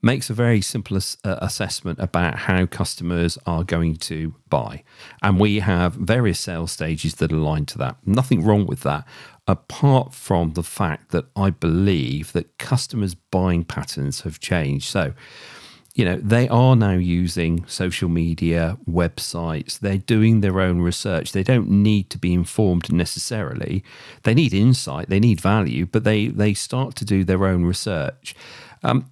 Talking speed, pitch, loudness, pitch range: 165 wpm, 95 Hz, -21 LUFS, 85-110 Hz